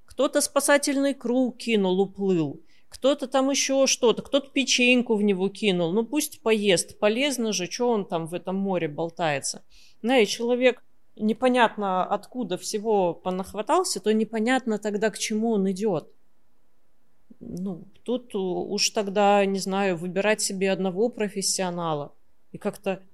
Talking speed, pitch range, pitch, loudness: 130 wpm, 190-245 Hz, 210 Hz, -24 LUFS